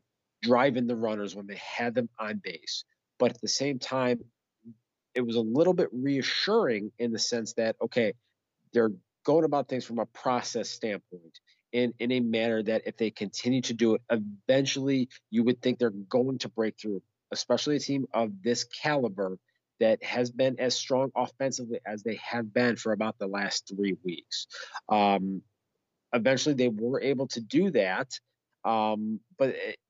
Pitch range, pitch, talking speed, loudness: 110-130 Hz, 120 Hz, 175 wpm, -29 LUFS